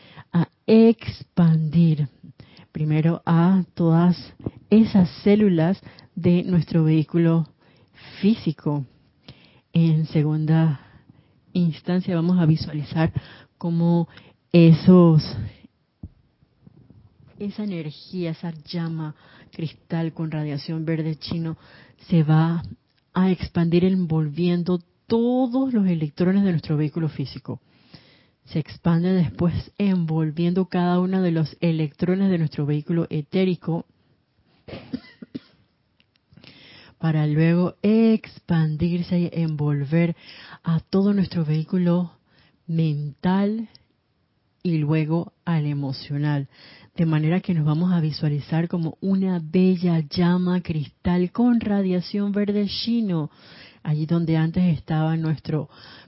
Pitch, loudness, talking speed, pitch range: 165 Hz, -22 LUFS, 95 wpm, 155-180 Hz